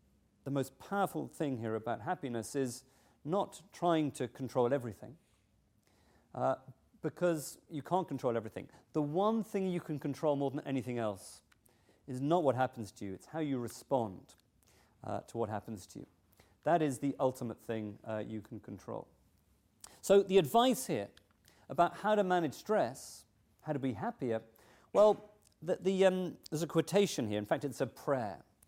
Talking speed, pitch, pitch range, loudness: 165 wpm, 135 Hz, 110-165 Hz, -35 LUFS